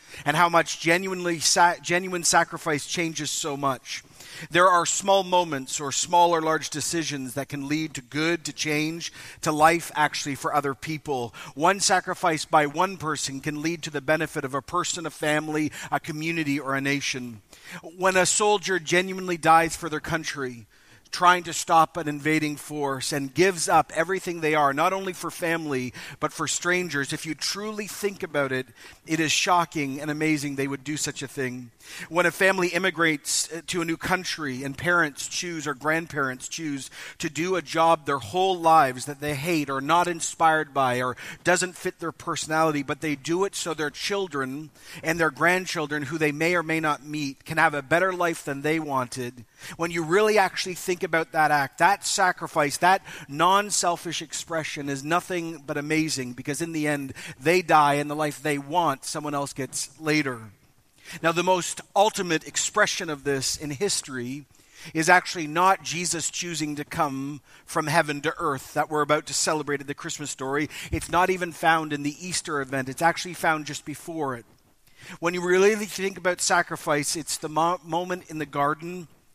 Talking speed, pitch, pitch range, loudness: 185 wpm, 160 Hz, 145-175 Hz, -25 LUFS